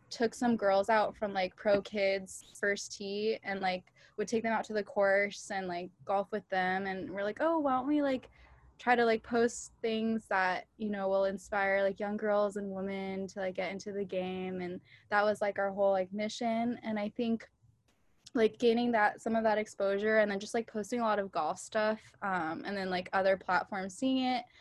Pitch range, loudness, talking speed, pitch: 195-225 Hz, -33 LUFS, 215 wpm, 205 Hz